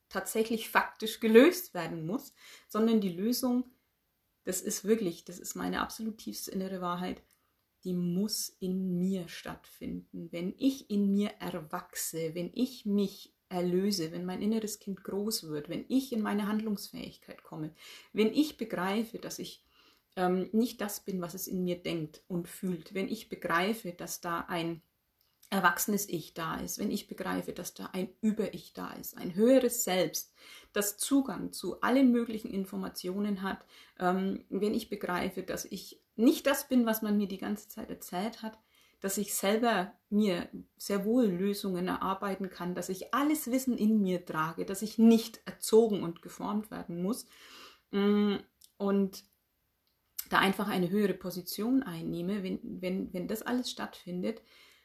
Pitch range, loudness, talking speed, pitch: 180-225 Hz, -32 LUFS, 155 wpm, 200 Hz